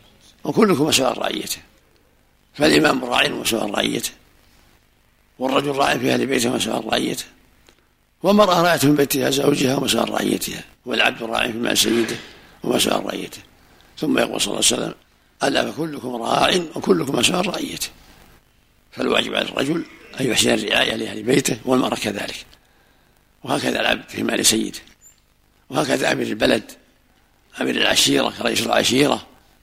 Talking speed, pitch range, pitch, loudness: 130 wpm, 115-145 Hz, 135 Hz, -19 LUFS